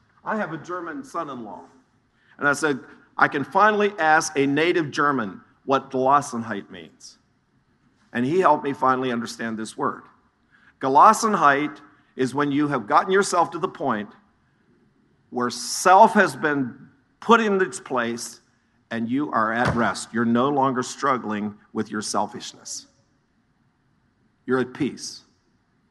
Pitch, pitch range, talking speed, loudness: 140 Hz, 120-165 Hz, 140 wpm, -22 LUFS